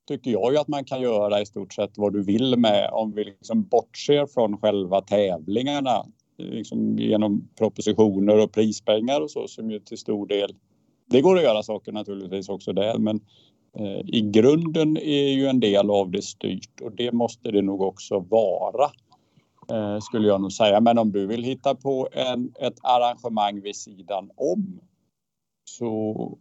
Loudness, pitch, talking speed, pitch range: -23 LUFS, 110 Hz, 175 wpm, 105-125 Hz